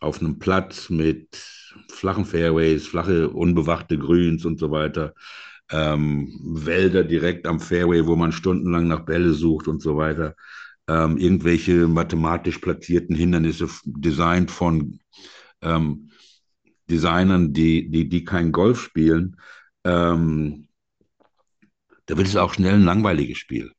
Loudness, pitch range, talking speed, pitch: -21 LUFS, 80-90 Hz, 125 wpm, 85 Hz